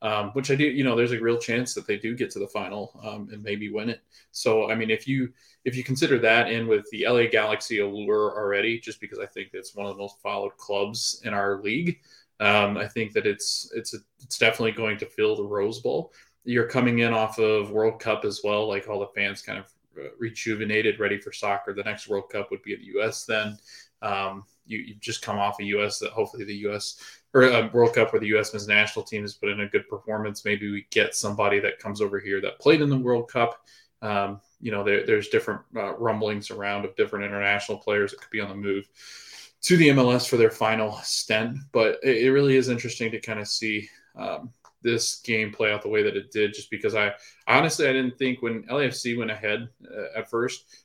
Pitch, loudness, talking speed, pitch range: 110 Hz, -25 LUFS, 235 wpm, 105-125 Hz